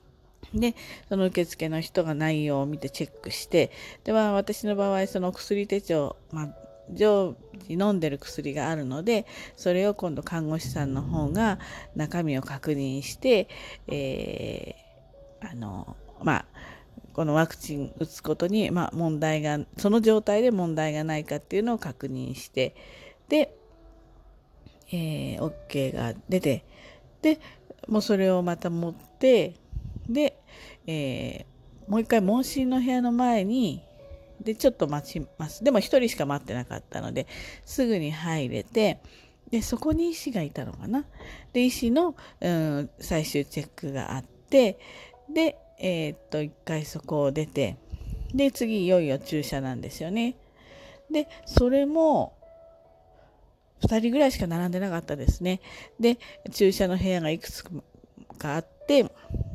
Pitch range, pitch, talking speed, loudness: 145-225 Hz, 175 Hz, 255 characters per minute, -27 LUFS